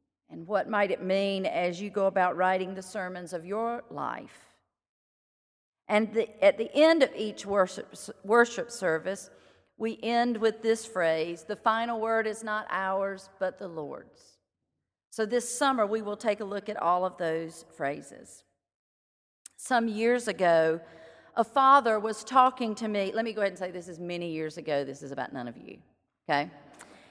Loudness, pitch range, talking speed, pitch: -28 LUFS, 170-225 Hz, 175 wpm, 200 Hz